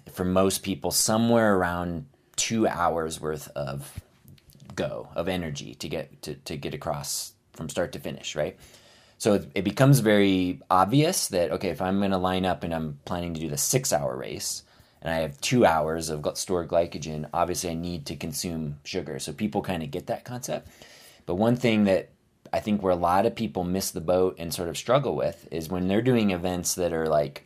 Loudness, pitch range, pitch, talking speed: -26 LUFS, 80-100 Hz, 90 Hz, 200 wpm